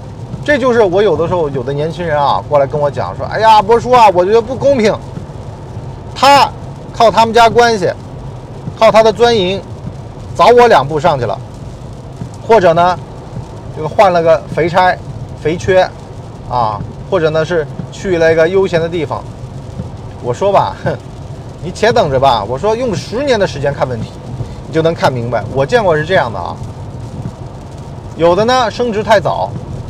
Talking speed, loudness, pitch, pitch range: 235 characters per minute, -12 LUFS, 140 Hz, 125-180 Hz